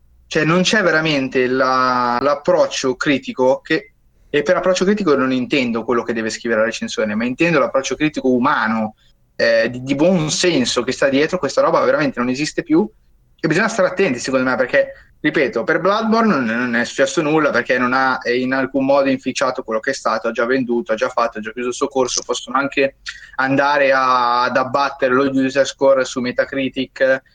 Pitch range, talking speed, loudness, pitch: 125-155 Hz, 190 wpm, -17 LUFS, 130 Hz